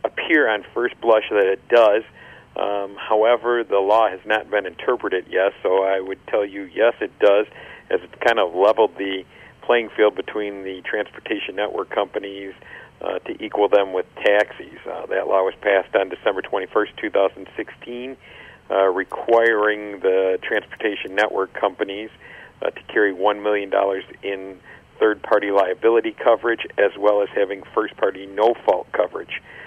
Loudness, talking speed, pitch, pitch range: -20 LUFS, 155 wpm, 100 Hz, 95-110 Hz